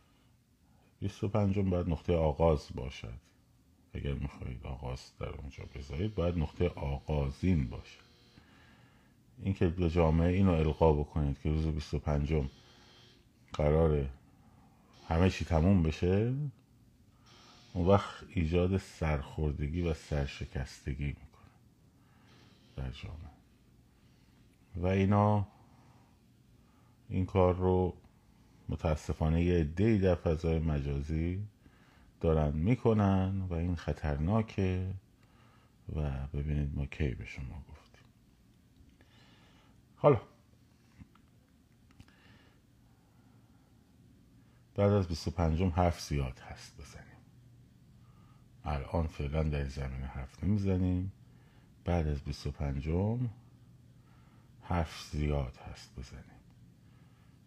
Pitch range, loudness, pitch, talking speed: 75-100 Hz, -33 LUFS, 85 Hz, 90 wpm